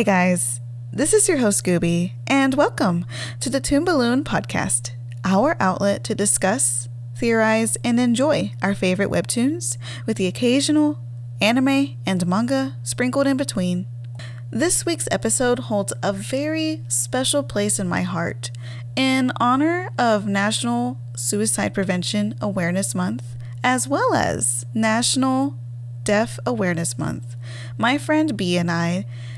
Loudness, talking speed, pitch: -21 LUFS, 130 wpm, 145 Hz